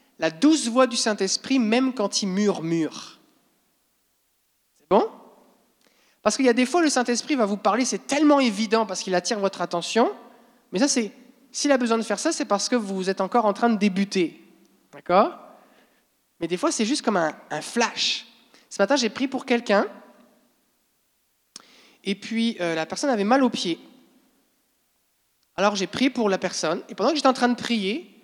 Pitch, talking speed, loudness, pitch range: 230 Hz, 185 wpm, -23 LUFS, 200-255 Hz